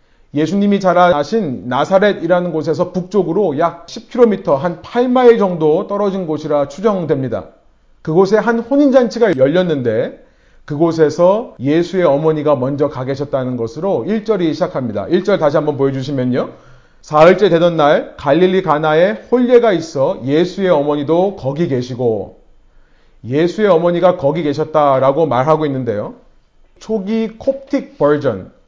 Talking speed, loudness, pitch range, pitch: 310 characters per minute, -14 LUFS, 145-200 Hz, 170 Hz